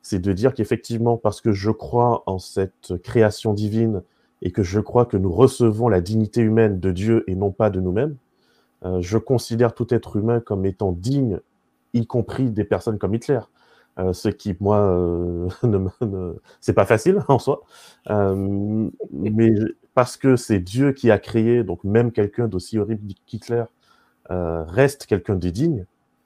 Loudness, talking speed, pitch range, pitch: -21 LUFS, 175 wpm, 95-120 Hz, 110 Hz